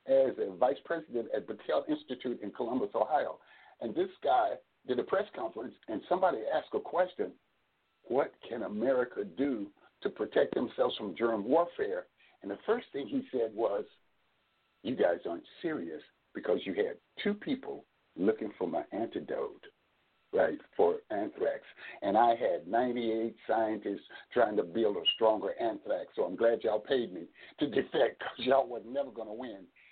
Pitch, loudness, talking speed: 335 Hz, -33 LUFS, 160 wpm